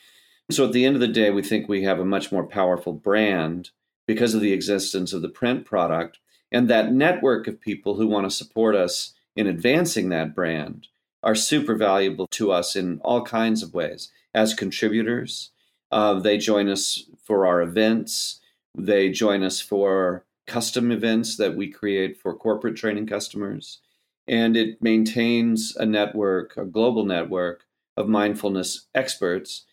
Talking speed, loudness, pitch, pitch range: 165 wpm, -23 LUFS, 105 Hz, 95-115 Hz